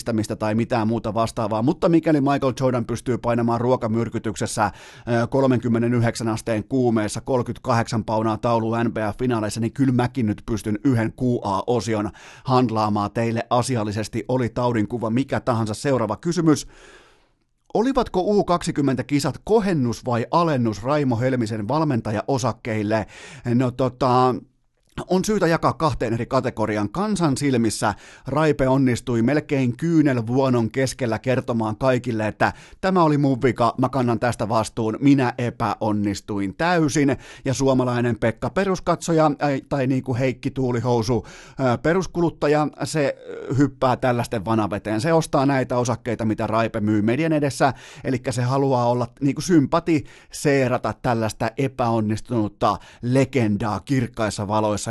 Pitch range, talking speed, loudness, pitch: 115-140 Hz, 120 wpm, -22 LUFS, 125 Hz